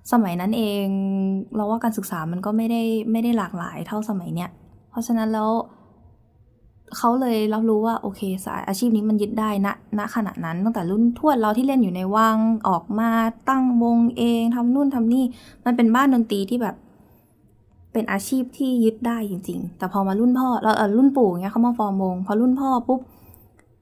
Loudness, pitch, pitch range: -21 LUFS, 220 Hz, 195-235 Hz